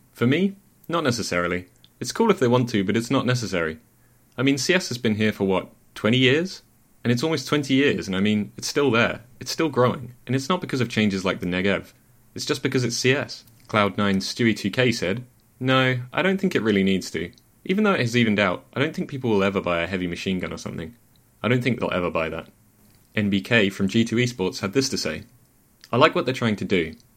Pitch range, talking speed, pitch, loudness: 100-130 Hz, 230 wpm, 120 Hz, -23 LUFS